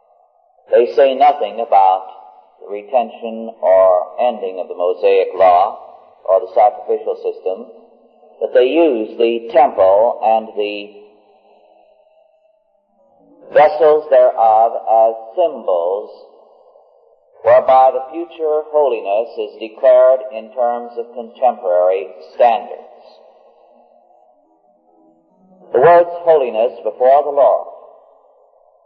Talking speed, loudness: 90 wpm, -14 LUFS